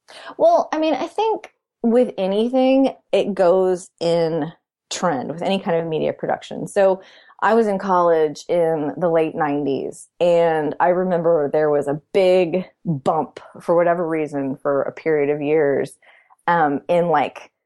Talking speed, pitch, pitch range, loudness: 155 wpm, 170 Hz, 155-190 Hz, -19 LUFS